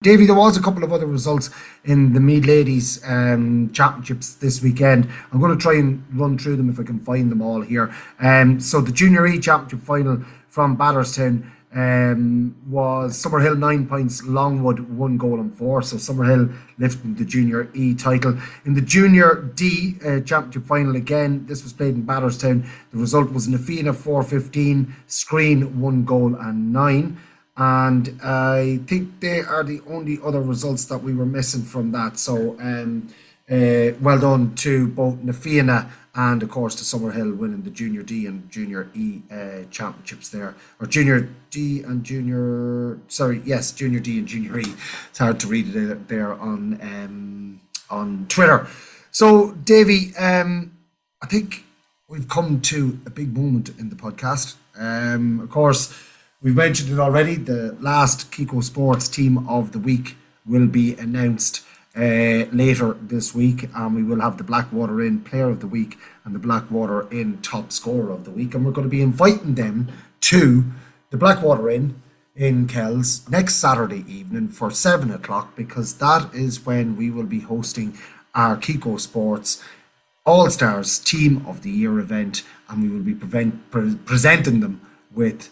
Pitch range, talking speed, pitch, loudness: 120-150 Hz, 170 wpm, 130 Hz, -19 LUFS